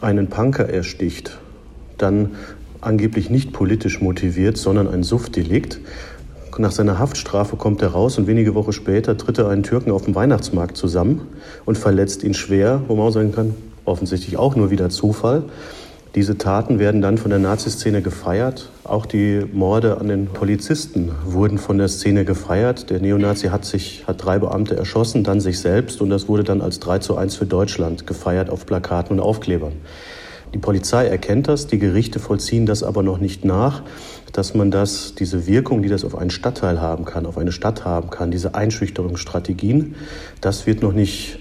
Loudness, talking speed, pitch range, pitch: -19 LUFS, 180 wpm, 95-110 Hz, 100 Hz